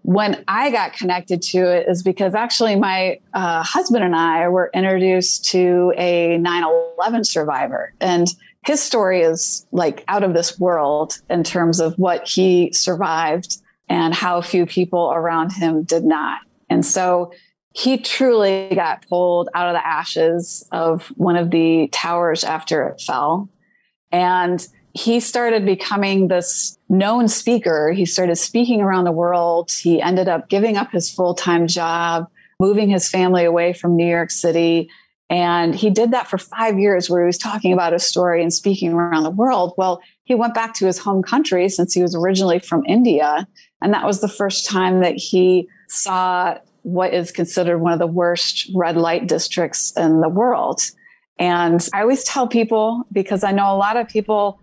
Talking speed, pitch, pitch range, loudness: 175 wpm, 180 Hz, 170-200 Hz, -17 LUFS